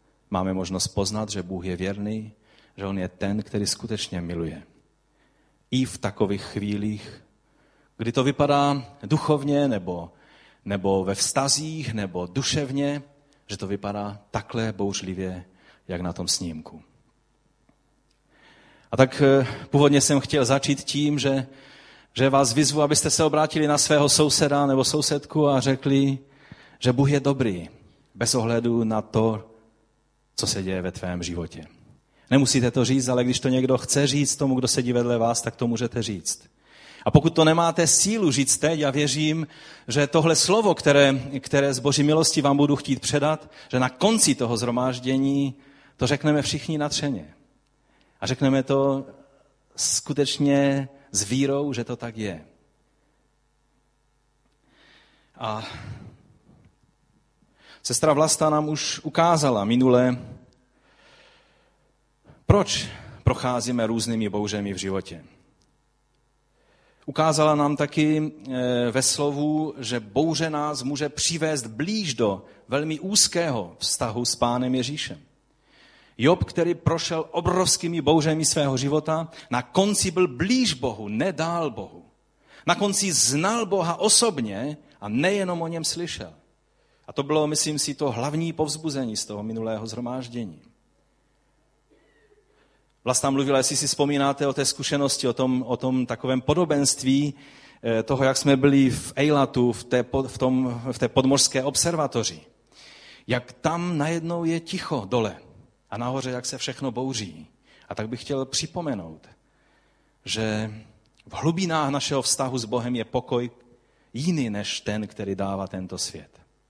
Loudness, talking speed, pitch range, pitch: -23 LUFS, 135 wpm, 115-150 Hz, 135 Hz